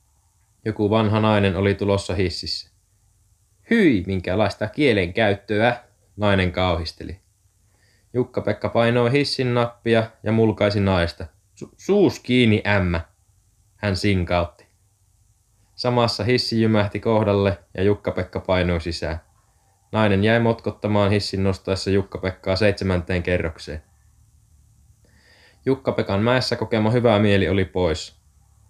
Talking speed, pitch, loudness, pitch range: 95 wpm, 100 Hz, -21 LUFS, 95-110 Hz